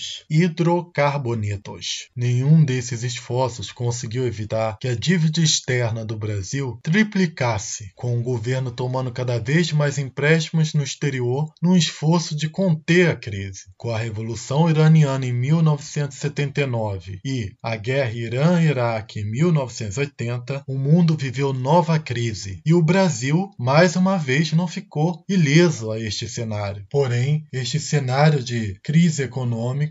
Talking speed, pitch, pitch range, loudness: 130 wpm, 135 Hz, 120-160 Hz, -21 LUFS